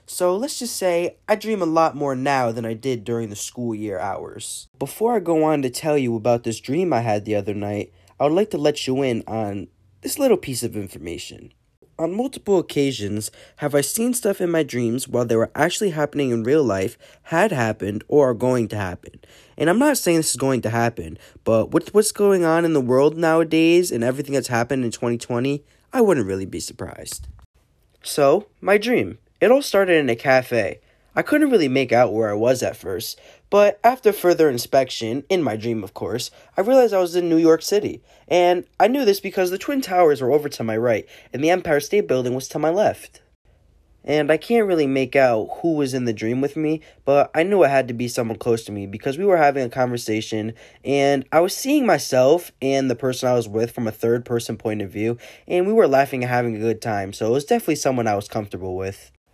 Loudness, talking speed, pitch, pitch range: -20 LUFS, 225 wpm, 135 Hz, 115-170 Hz